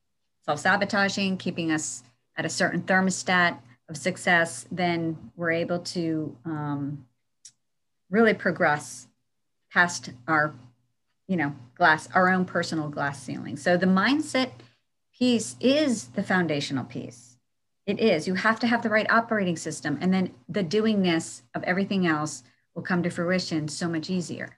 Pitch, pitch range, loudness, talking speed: 170 Hz, 145-185 Hz, -25 LUFS, 140 wpm